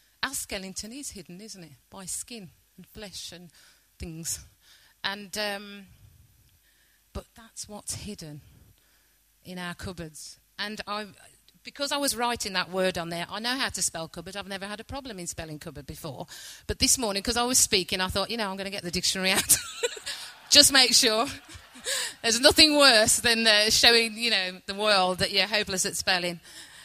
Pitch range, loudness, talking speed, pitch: 175-225 Hz, -23 LUFS, 185 wpm, 200 Hz